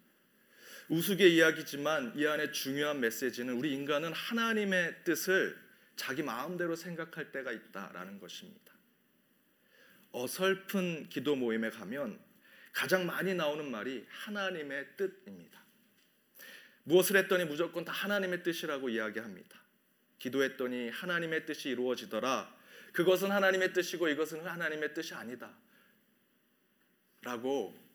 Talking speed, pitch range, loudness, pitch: 300 characters per minute, 145-190 Hz, -33 LUFS, 170 Hz